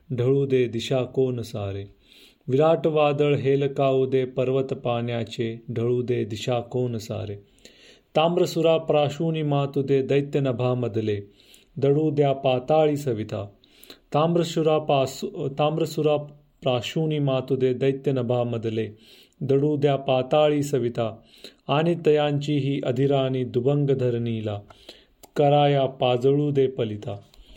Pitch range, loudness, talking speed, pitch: 120-145 Hz, -23 LUFS, 100 wpm, 135 Hz